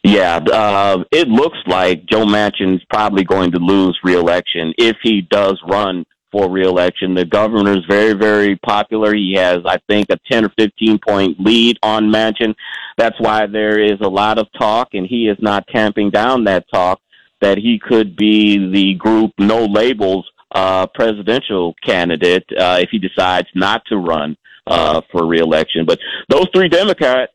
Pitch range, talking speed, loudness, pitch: 95-110 Hz, 165 wpm, -14 LUFS, 105 Hz